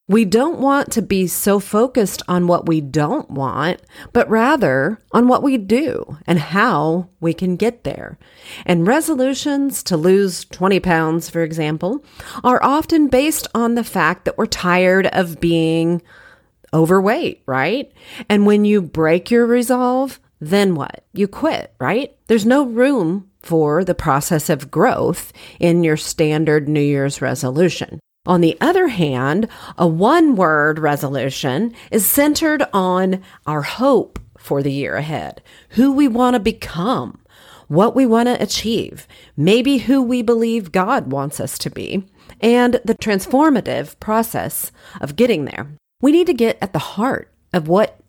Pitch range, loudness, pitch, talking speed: 165-245 Hz, -17 LUFS, 195 Hz, 150 wpm